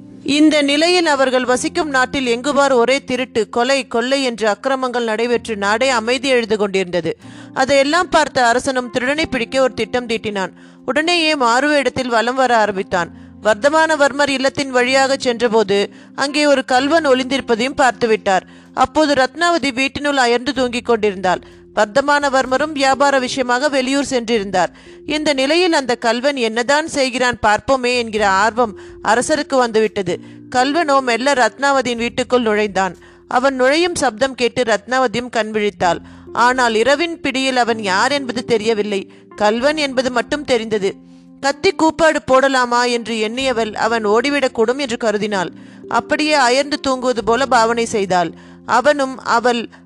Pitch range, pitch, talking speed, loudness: 225-275 Hz, 250 Hz, 125 wpm, -16 LUFS